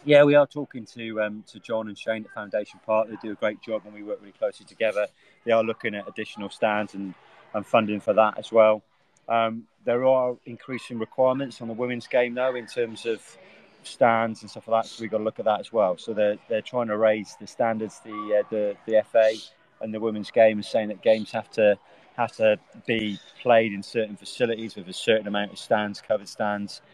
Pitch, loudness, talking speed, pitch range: 110 Hz, -25 LUFS, 225 wpm, 105-115 Hz